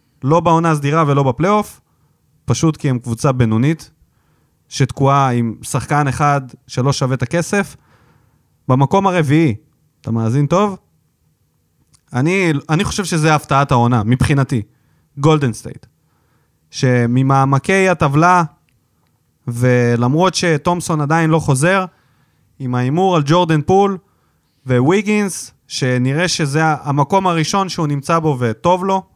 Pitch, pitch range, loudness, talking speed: 145 Hz, 130-170 Hz, -15 LUFS, 110 wpm